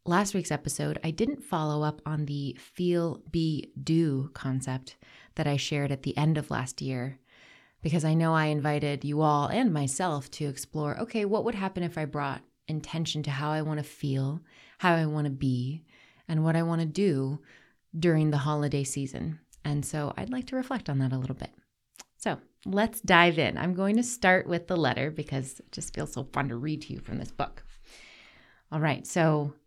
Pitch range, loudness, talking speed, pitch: 140-170 Hz, -29 LUFS, 200 wpm, 150 Hz